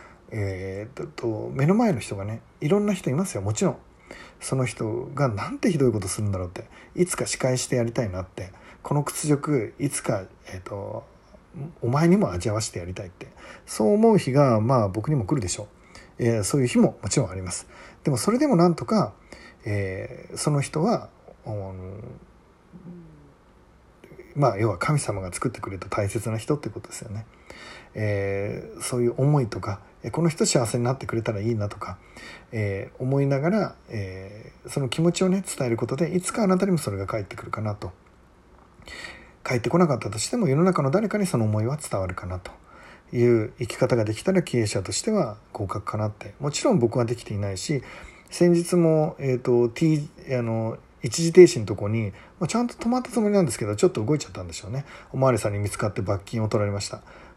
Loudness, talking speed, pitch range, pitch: -24 LUFS, 385 characters per minute, 105-155 Hz, 120 Hz